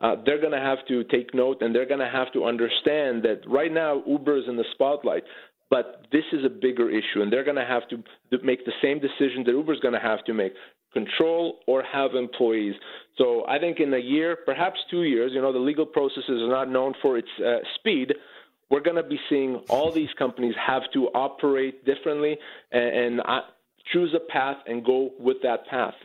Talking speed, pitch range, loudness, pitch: 215 wpm, 125-150 Hz, -25 LUFS, 135 Hz